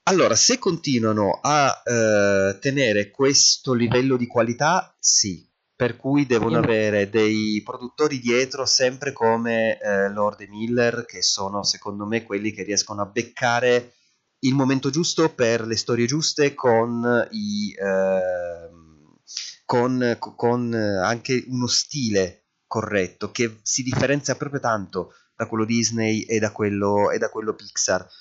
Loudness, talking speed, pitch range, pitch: -21 LUFS, 135 wpm, 105-130 Hz, 115 Hz